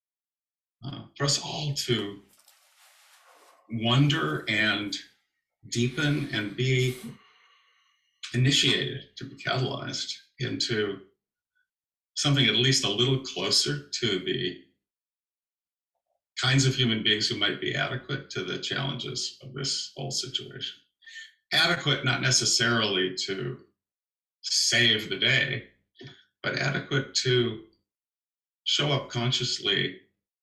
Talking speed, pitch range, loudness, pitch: 100 wpm, 105-140 Hz, -26 LUFS, 125 Hz